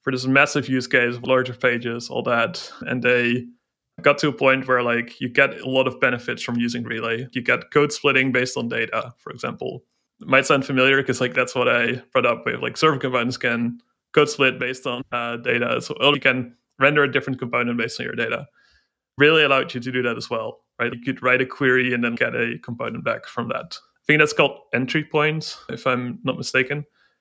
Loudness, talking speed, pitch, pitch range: -21 LUFS, 225 wpm, 130 Hz, 120-140 Hz